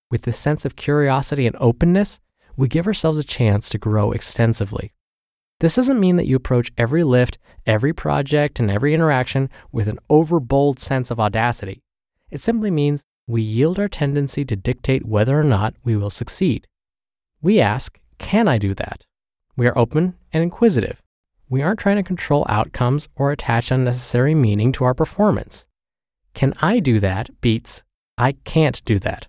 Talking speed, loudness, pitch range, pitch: 170 wpm, -19 LUFS, 115-150 Hz, 130 Hz